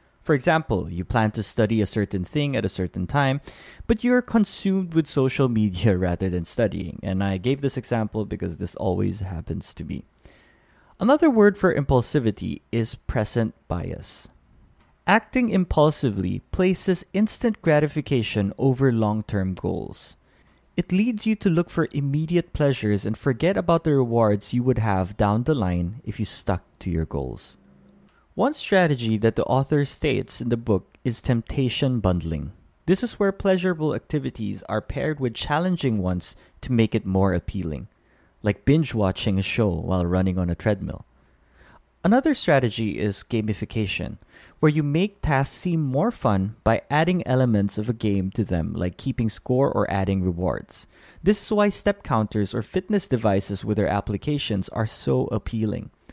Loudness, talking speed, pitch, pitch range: -23 LUFS, 160 wpm, 115 Hz, 100-150 Hz